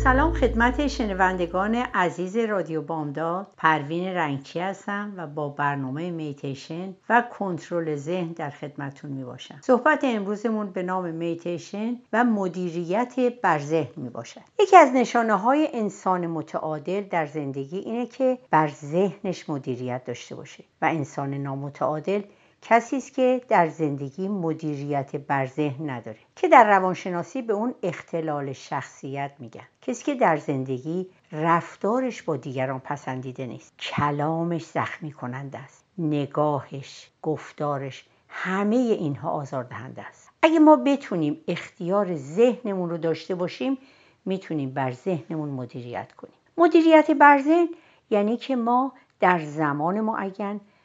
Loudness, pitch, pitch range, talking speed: -24 LUFS, 170 Hz, 145-215 Hz, 130 wpm